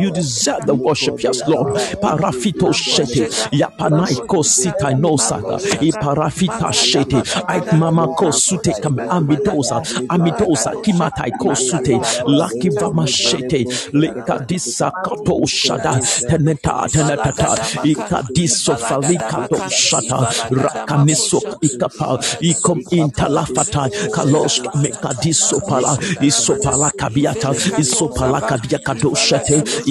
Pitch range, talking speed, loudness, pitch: 135-165 Hz, 95 wpm, -16 LUFS, 150 Hz